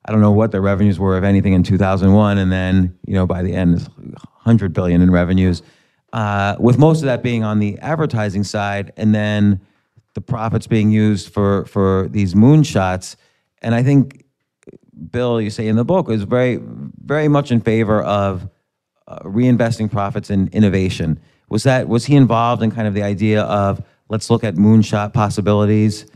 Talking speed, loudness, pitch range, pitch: 185 wpm, -16 LUFS, 100-115 Hz, 105 Hz